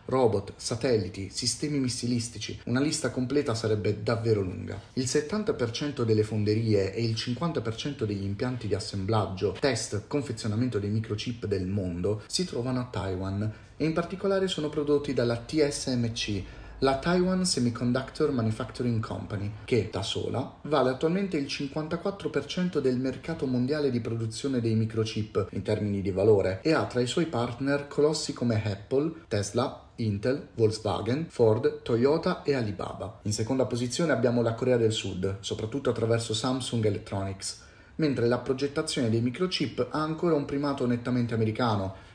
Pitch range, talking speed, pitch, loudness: 110-145 Hz, 140 wpm, 120 Hz, -29 LUFS